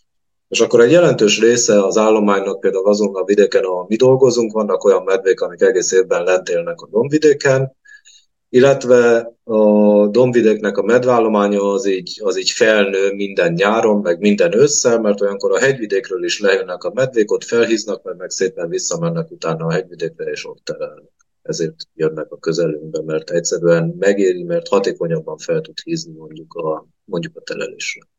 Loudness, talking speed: -15 LUFS, 160 wpm